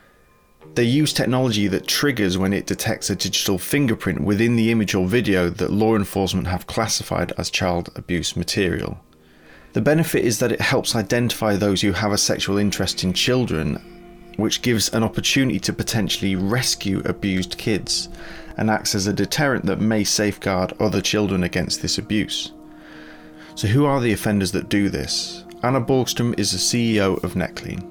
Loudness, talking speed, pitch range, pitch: -20 LUFS, 165 wpm, 90-120 Hz, 100 Hz